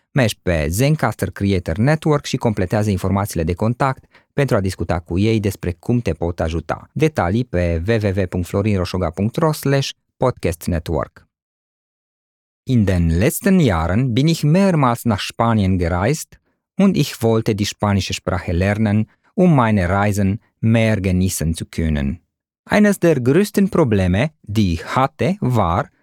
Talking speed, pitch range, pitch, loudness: 130 wpm, 90-130 Hz, 105 Hz, -18 LUFS